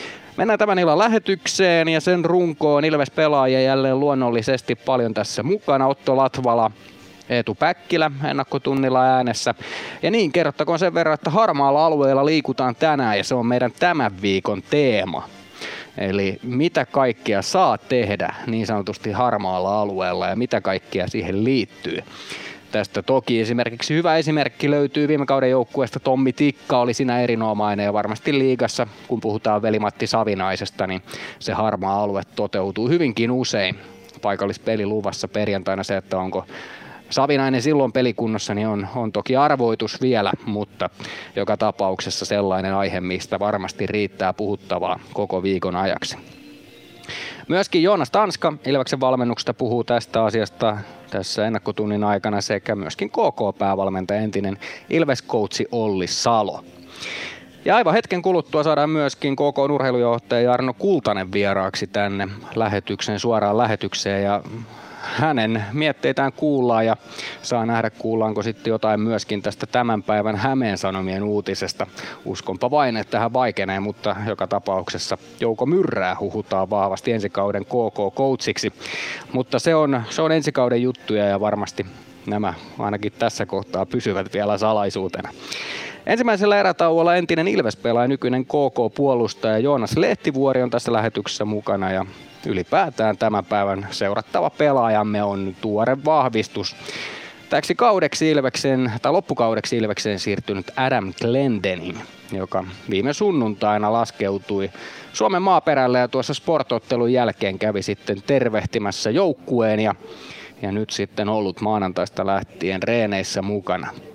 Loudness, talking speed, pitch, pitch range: -21 LUFS, 125 wpm, 115 Hz, 100-135 Hz